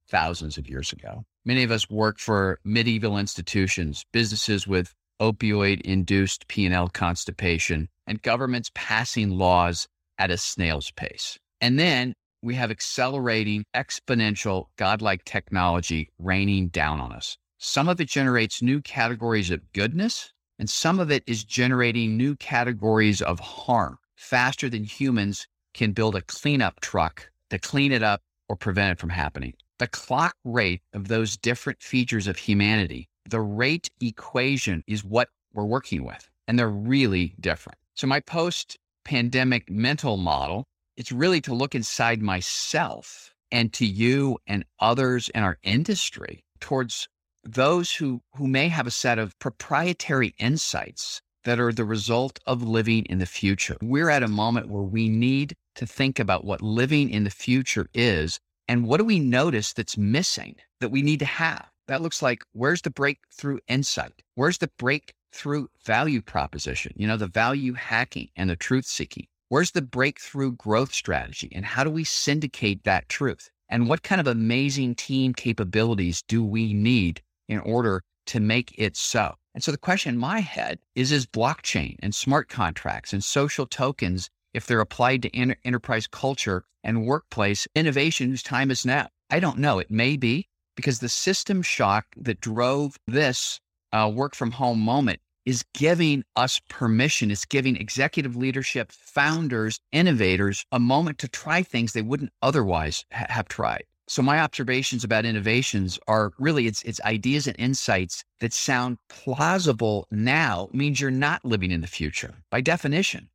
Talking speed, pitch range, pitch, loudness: 160 wpm, 100-135 Hz, 120 Hz, -24 LUFS